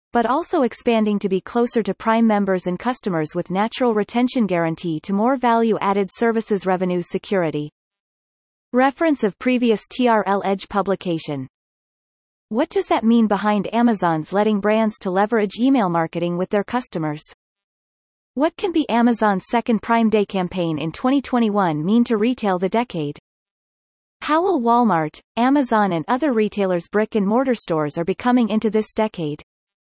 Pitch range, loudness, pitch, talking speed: 185-240 Hz, -20 LUFS, 210 Hz, 150 wpm